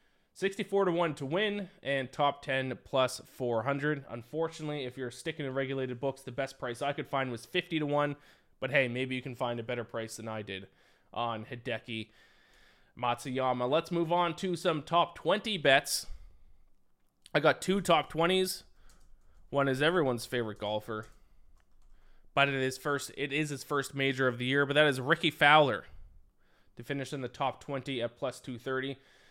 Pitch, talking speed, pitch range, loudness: 135 Hz, 175 wpm, 115-150 Hz, -31 LUFS